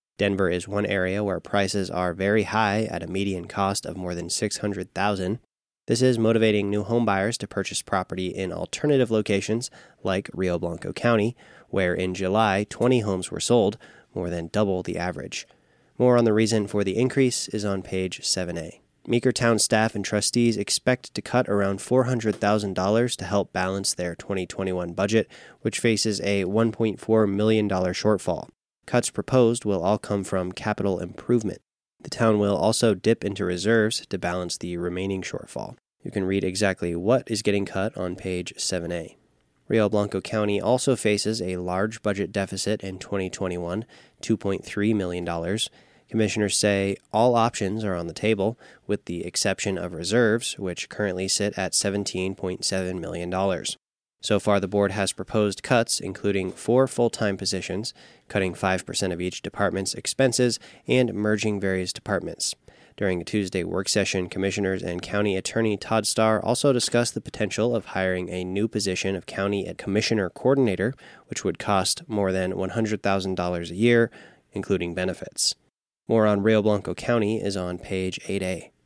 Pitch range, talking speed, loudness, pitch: 95-110 Hz, 165 wpm, -25 LUFS, 100 Hz